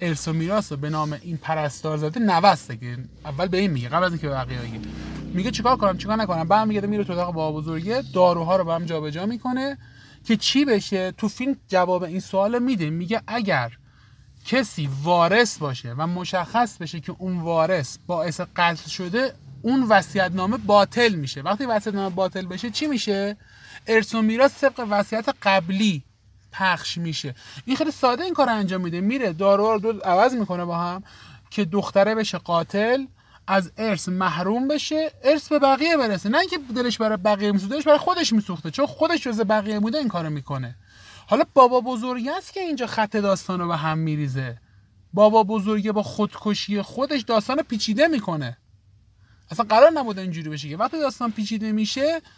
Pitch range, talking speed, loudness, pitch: 165-235 Hz, 170 wpm, -22 LUFS, 200 Hz